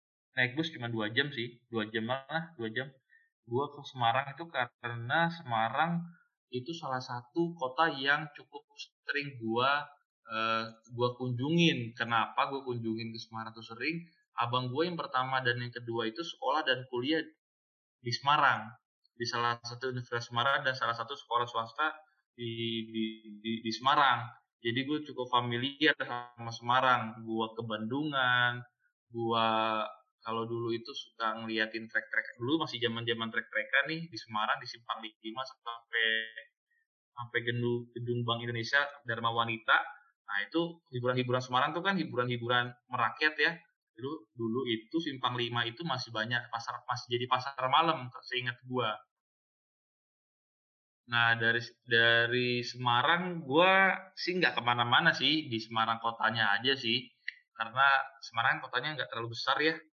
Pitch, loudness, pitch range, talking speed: 120 Hz, -32 LUFS, 115-145 Hz, 145 wpm